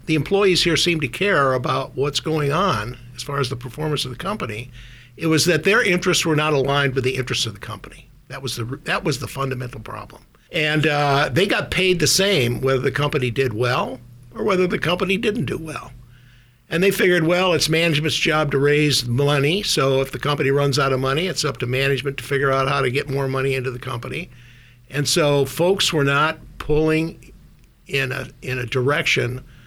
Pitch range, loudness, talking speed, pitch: 130-155 Hz, -20 LUFS, 210 wpm, 140 Hz